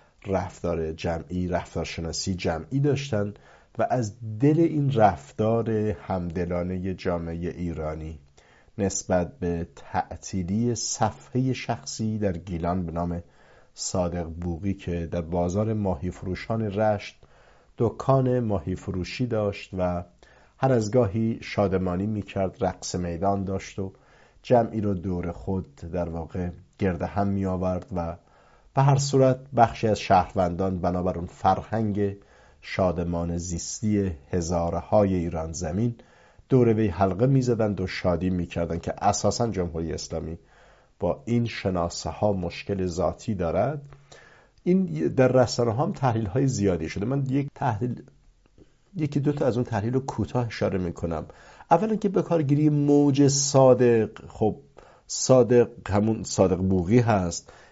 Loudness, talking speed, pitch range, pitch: -25 LUFS, 125 wpm, 90-120 Hz, 95 Hz